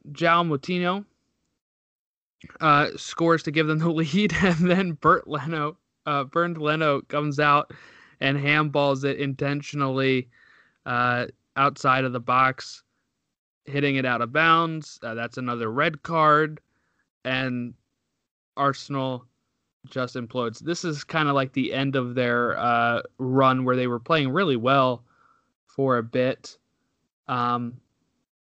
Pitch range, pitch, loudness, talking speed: 125-155 Hz, 135 Hz, -23 LUFS, 130 wpm